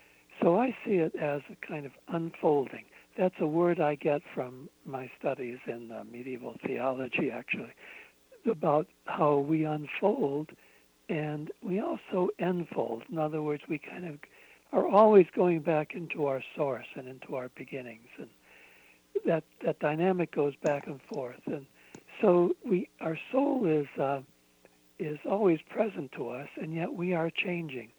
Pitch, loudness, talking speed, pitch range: 155 Hz, -31 LUFS, 155 wpm, 140-180 Hz